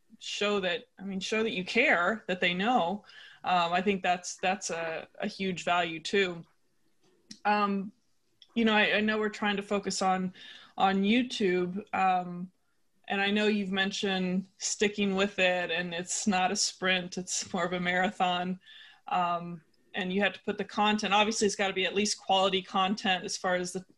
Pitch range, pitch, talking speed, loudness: 185-210 Hz, 195 Hz, 185 wpm, -29 LUFS